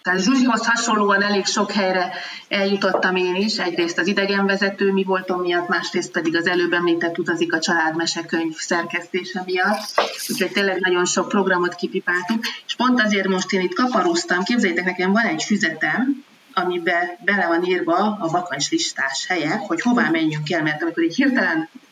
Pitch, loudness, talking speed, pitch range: 185 Hz, -20 LUFS, 160 wpm, 175-210 Hz